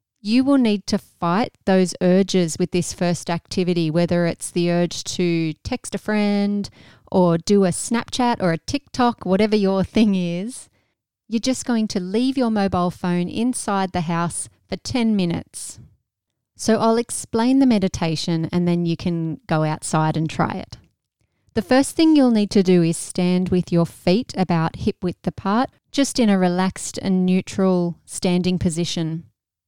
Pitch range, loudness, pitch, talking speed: 175-215 Hz, -20 LUFS, 185 Hz, 165 wpm